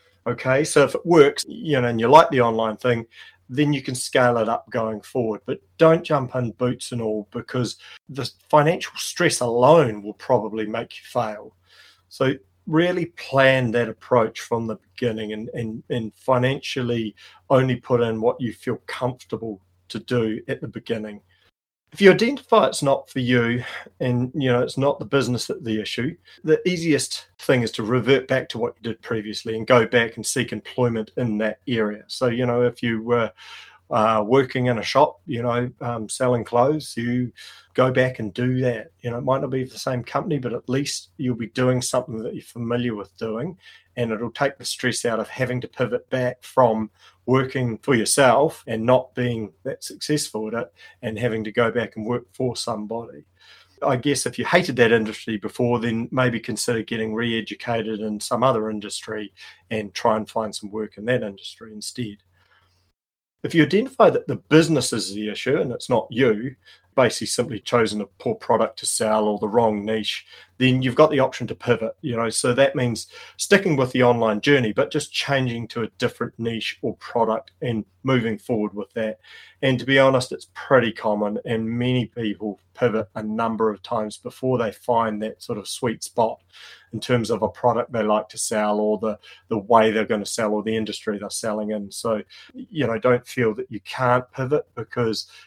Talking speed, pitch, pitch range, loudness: 195 wpm, 120 Hz, 110-130 Hz, -22 LUFS